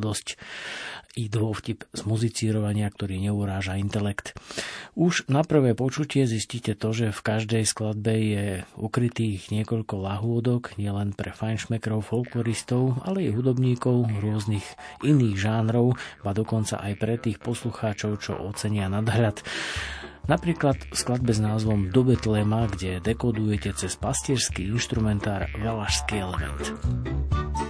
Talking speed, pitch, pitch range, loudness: 115 wpm, 110 Hz, 100-115 Hz, -26 LUFS